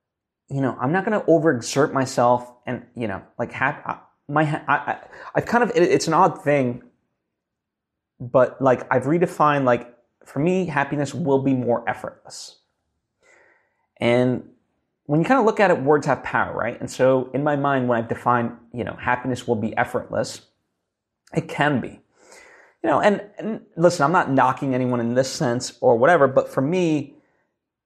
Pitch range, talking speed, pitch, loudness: 125-165 Hz, 175 wpm, 135 Hz, -21 LUFS